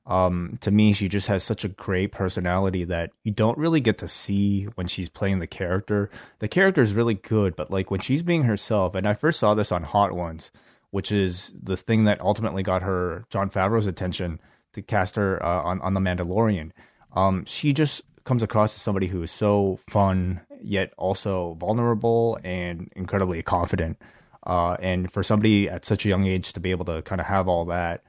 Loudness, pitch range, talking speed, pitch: -24 LUFS, 90-105 Hz, 205 wpm, 95 Hz